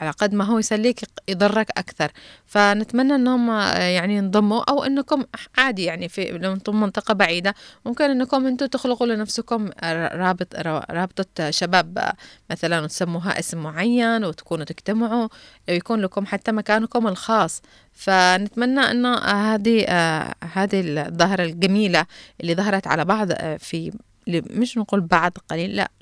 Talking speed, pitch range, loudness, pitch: 125 wpm, 175-230 Hz, -21 LUFS, 200 Hz